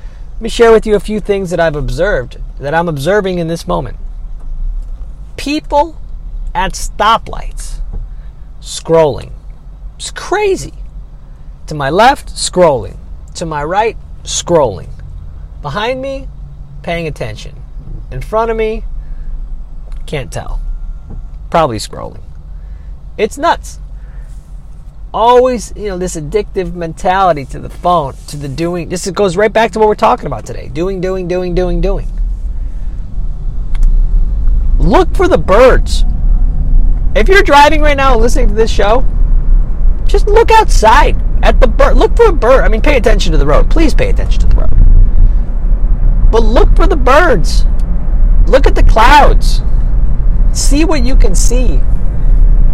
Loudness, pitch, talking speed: -12 LUFS, 170 Hz, 140 wpm